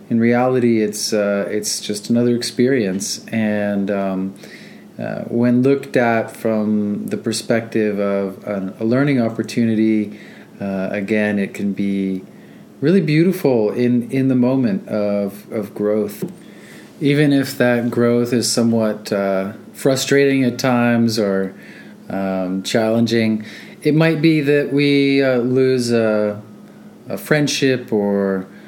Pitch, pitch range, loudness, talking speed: 115 Hz, 105-130 Hz, -18 LUFS, 125 wpm